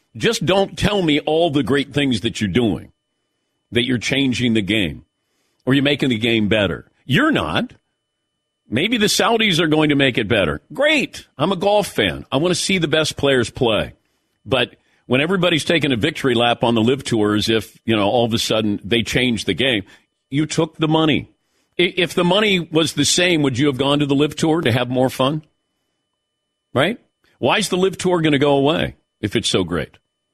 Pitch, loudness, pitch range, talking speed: 145 Hz, -18 LUFS, 120-170 Hz, 210 wpm